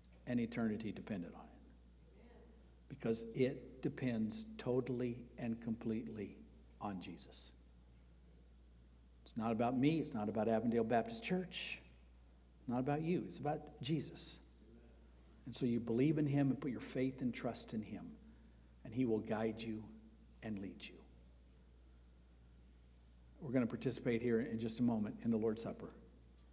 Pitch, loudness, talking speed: 110 Hz, -41 LUFS, 145 wpm